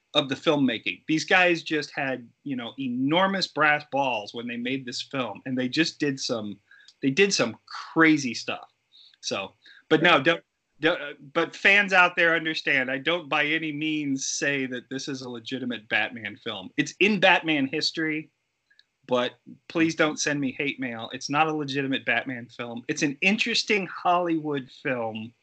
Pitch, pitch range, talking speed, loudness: 150 Hz, 130-165 Hz, 170 wpm, -25 LUFS